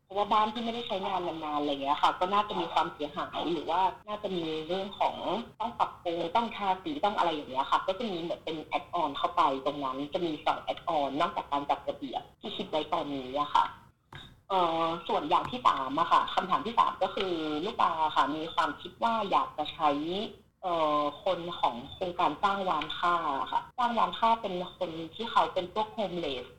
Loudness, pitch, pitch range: -30 LUFS, 180 Hz, 155-210 Hz